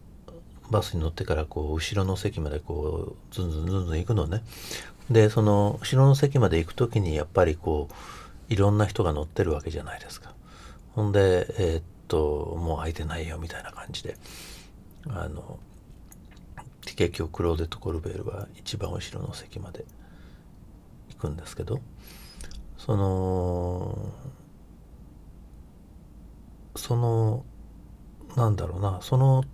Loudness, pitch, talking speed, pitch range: -27 LUFS, 95 Hz, 280 characters per minute, 80-105 Hz